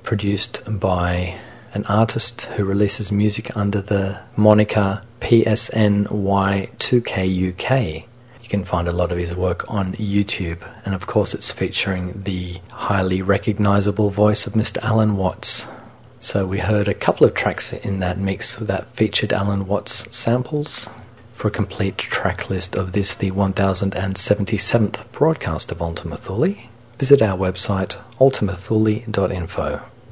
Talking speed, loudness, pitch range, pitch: 130 wpm, -20 LUFS, 95-110 Hz, 105 Hz